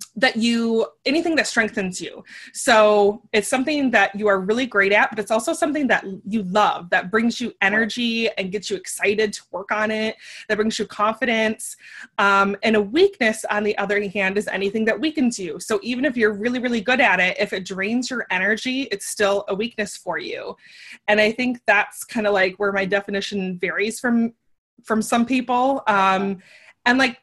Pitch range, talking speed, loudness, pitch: 200-240 Hz, 195 wpm, -20 LUFS, 215 Hz